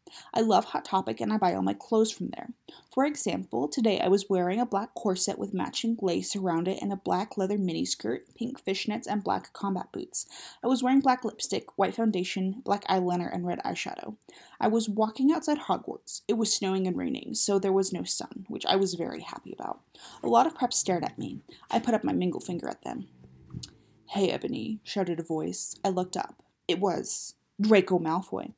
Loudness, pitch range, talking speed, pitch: -29 LUFS, 185-230 Hz, 205 wpm, 200 Hz